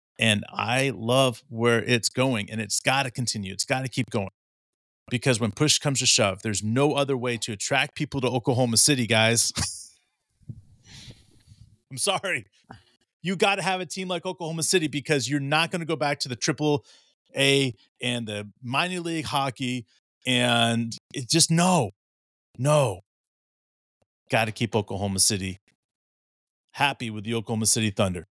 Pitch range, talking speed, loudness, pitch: 110-145 Hz, 160 wpm, -24 LUFS, 125 Hz